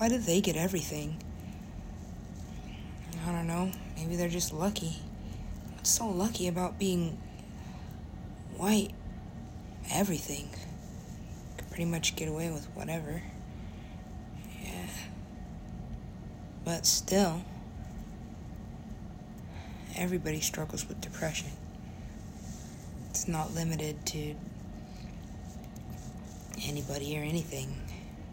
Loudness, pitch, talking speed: -35 LUFS, 140 Hz, 85 wpm